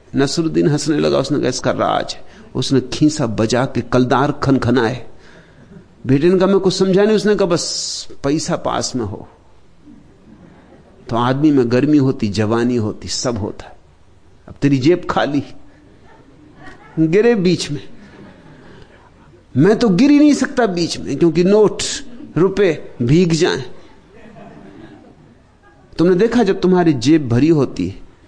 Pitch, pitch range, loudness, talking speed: 145 Hz, 120-180 Hz, -16 LUFS, 140 wpm